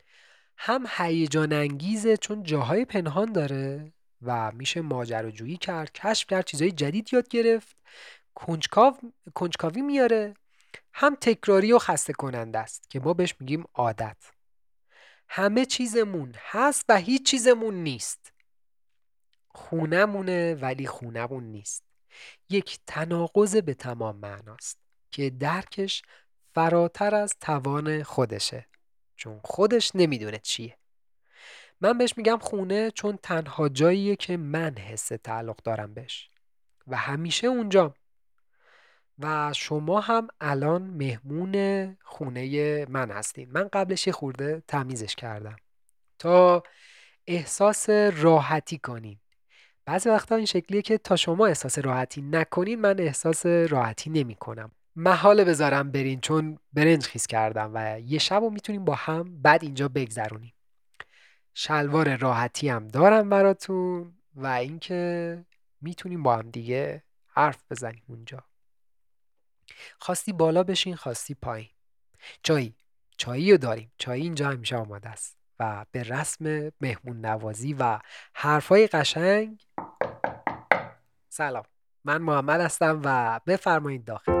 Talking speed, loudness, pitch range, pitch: 115 wpm, -25 LUFS, 125-190 Hz, 155 Hz